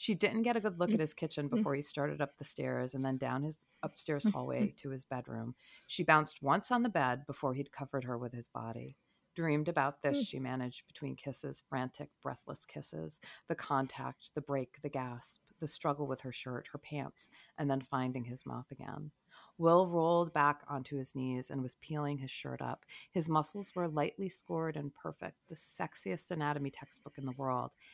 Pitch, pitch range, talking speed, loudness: 145 Hz, 130-160 Hz, 200 wpm, -37 LUFS